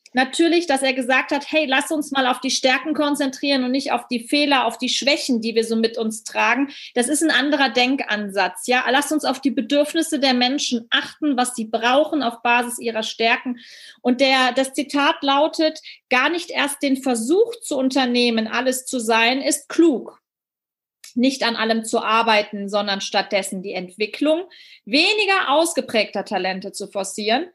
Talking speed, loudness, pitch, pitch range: 170 wpm, -19 LUFS, 260 Hz, 230-290 Hz